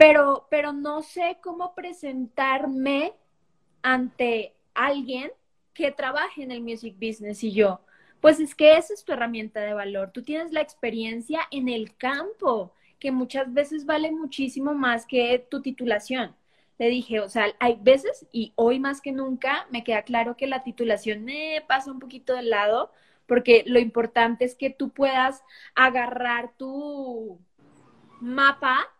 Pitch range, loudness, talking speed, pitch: 235-285 Hz, -24 LUFS, 155 wpm, 260 Hz